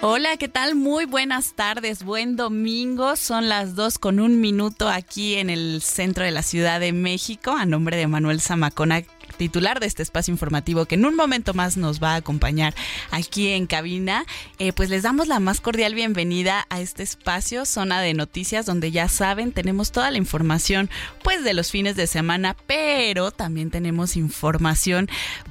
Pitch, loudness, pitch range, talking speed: 190 Hz, -22 LUFS, 170-220 Hz, 180 wpm